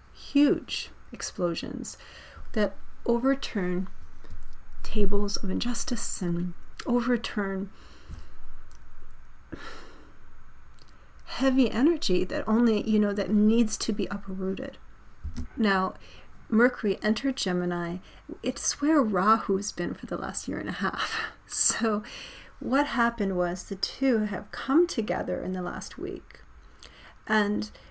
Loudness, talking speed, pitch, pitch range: -27 LUFS, 105 wpm, 210 Hz, 185-245 Hz